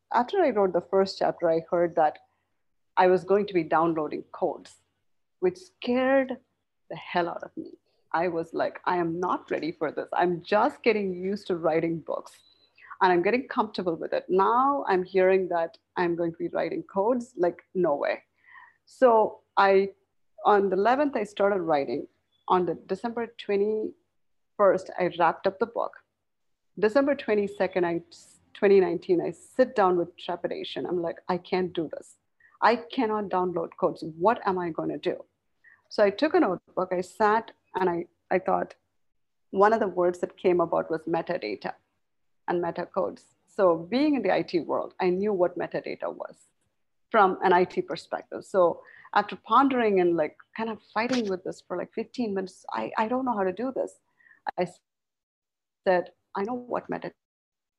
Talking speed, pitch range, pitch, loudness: 170 wpm, 175-235 Hz, 195 Hz, -26 LUFS